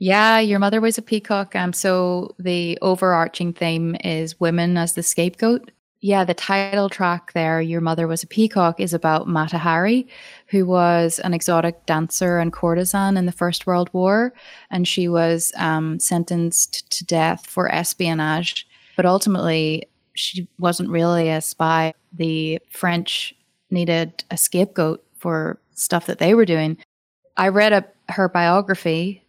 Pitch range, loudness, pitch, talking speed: 165-190 Hz, -20 LUFS, 175 Hz, 150 wpm